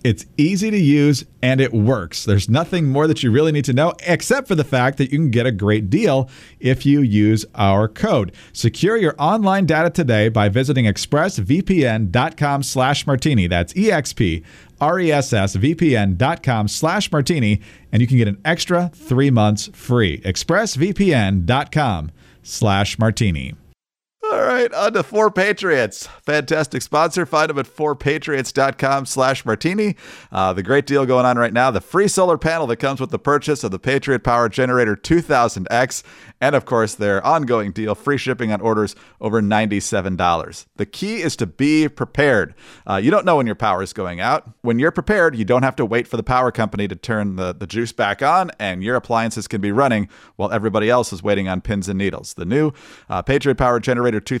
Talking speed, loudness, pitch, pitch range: 180 wpm, -18 LUFS, 125 Hz, 105-150 Hz